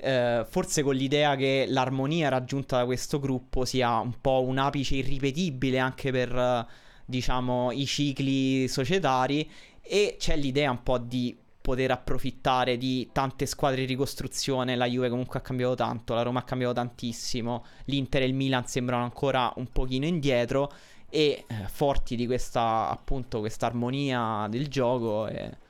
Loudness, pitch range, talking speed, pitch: -28 LUFS, 125-140 Hz, 155 wpm, 130 Hz